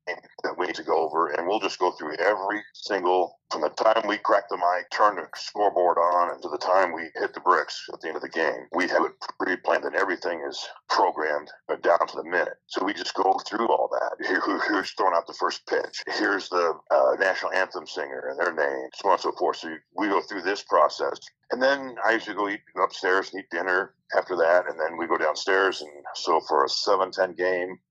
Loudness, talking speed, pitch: -25 LUFS, 235 wpm, 375 Hz